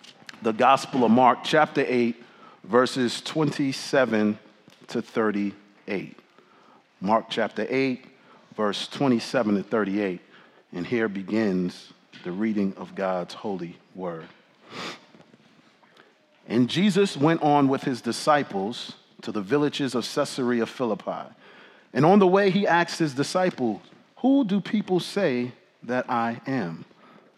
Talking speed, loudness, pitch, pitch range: 120 wpm, -24 LUFS, 125 Hz, 105-155 Hz